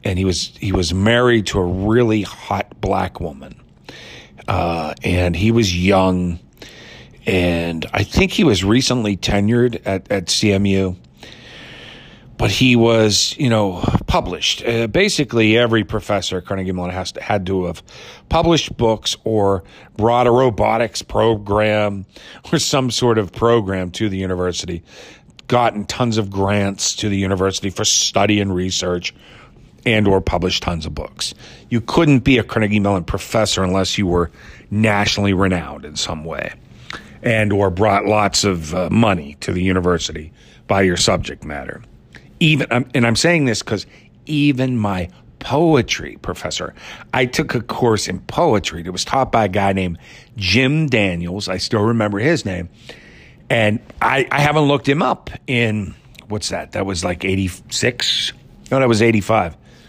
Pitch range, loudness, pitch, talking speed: 95-120 Hz, -17 LUFS, 105 Hz, 155 wpm